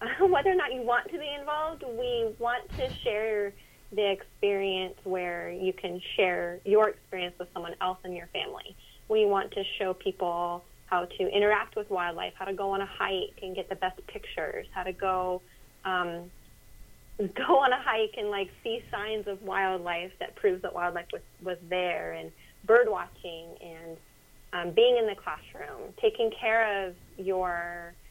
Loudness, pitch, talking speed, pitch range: -30 LUFS, 195 Hz, 175 wpm, 180-225 Hz